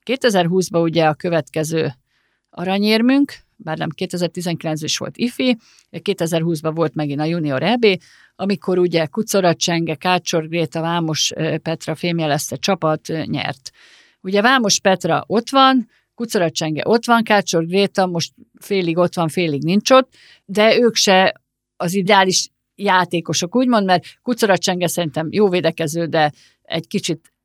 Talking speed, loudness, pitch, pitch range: 130 wpm, -18 LUFS, 175 Hz, 160-200 Hz